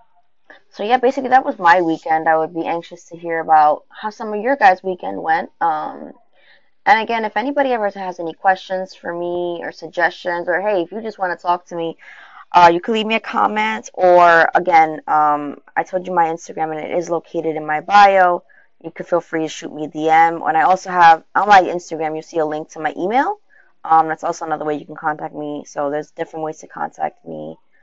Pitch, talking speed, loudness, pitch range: 170 Hz, 225 wpm, -17 LUFS, 160-200 Hz